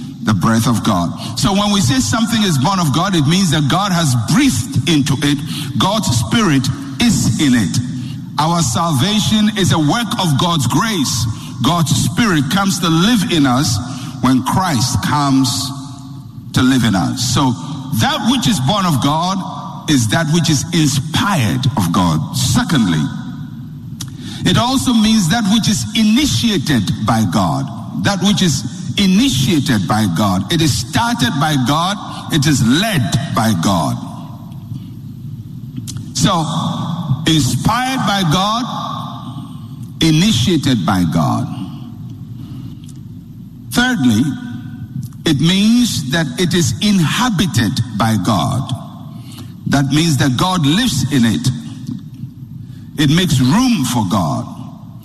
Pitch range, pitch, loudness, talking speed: 130-185 Hz, 145 Hz, -15 LUFS, 125 wpm